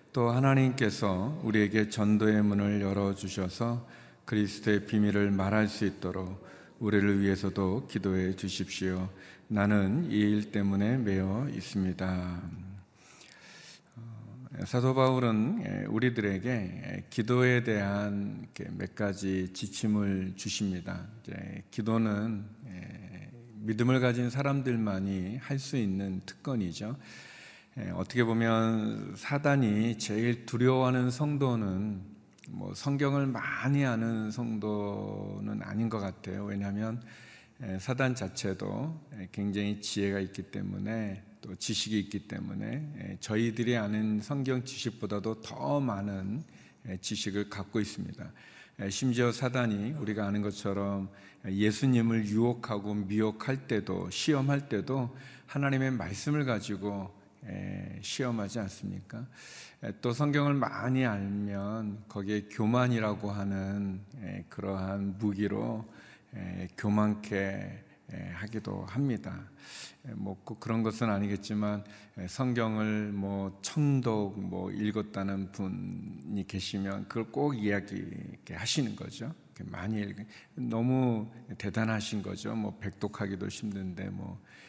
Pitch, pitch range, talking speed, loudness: 105 Hz, 100-120 Hz, 245 characters per minute, -32 LUFS